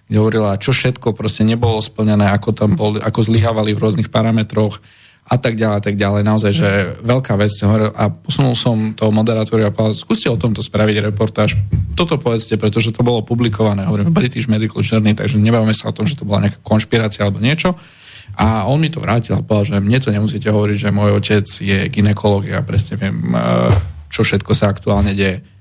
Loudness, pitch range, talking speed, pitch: -15 LUFS, 100-115 Hz, 200 wpm, 110 Hz